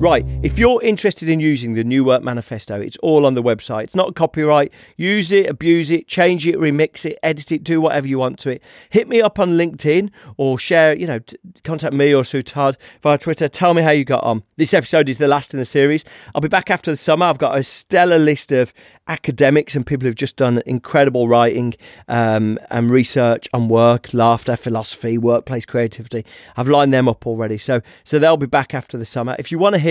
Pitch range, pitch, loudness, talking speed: 120-160 Hz, 140 Hz, -17 LUFS, 225 wpm